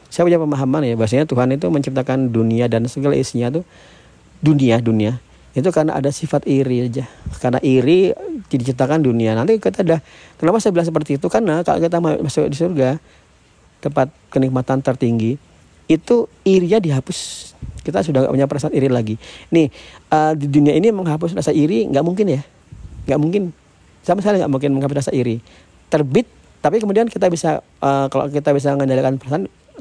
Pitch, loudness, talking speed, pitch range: 140 Hz, -17 LUFS, 165 wpm, 130-165 Hz